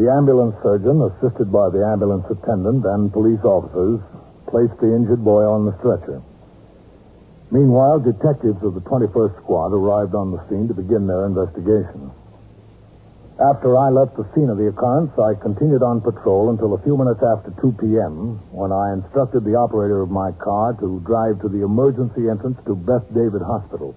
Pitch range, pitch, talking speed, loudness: 100-125 Hz, 110 Hz, 175 wpm, -18 LUFS